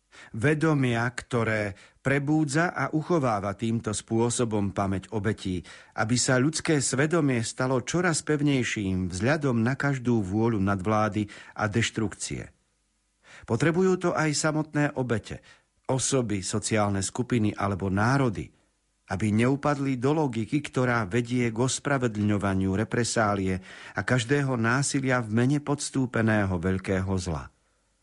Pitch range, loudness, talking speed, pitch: 105-140 Hz, -26 LUFS, 105 wpm, 120 Hz